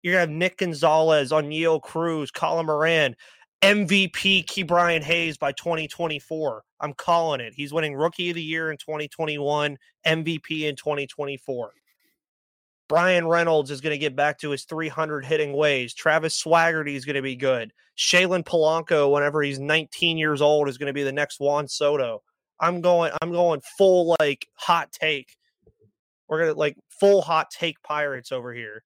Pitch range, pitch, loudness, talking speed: 145-170 Hz, 155 Hz, -23 LUFS, 160 wpm